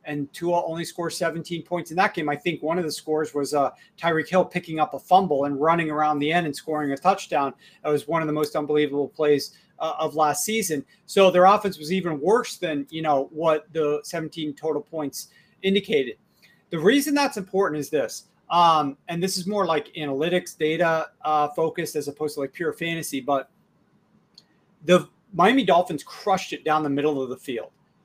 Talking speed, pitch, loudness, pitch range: 200 wpm, 160 Hz, -24 LUFS, 150-180 Hz